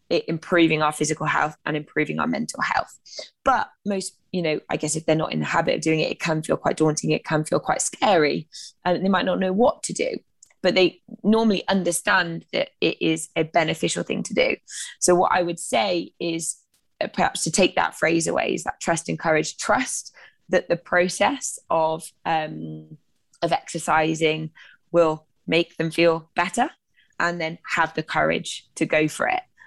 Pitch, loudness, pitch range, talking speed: 165 Hz, -23 LUFS, 155-180 Hz, 190 wpm